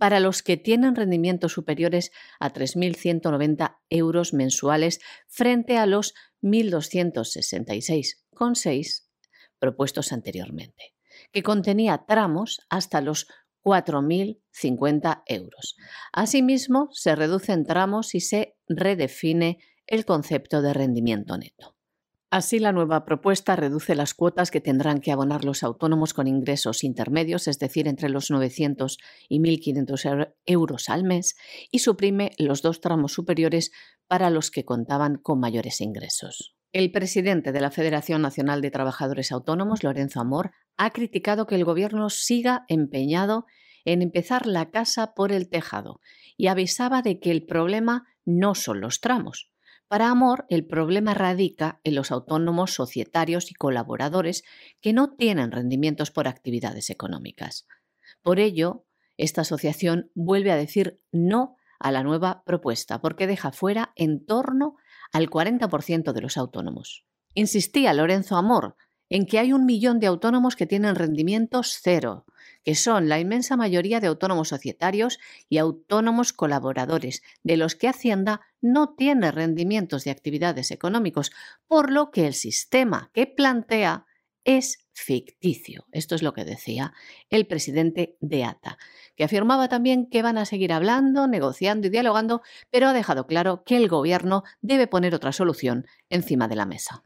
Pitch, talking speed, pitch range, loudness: 175 Hz, 140 wpm, 145-210 Hz, -24 LUFS